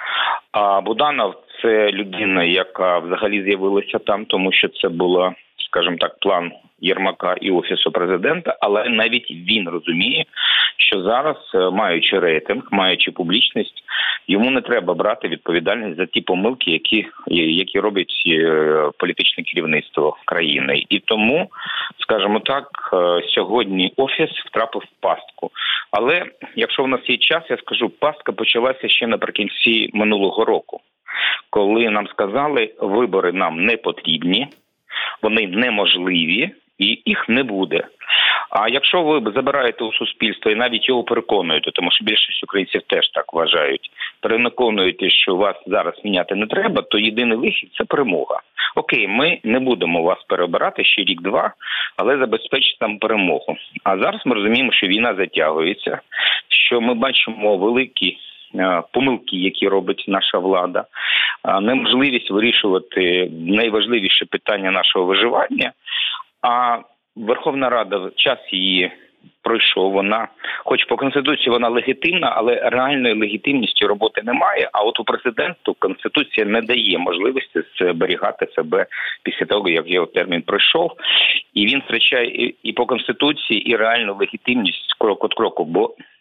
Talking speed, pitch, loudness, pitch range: 130 wpm, 110 Hz, -17 LUFS, 95-120 Hz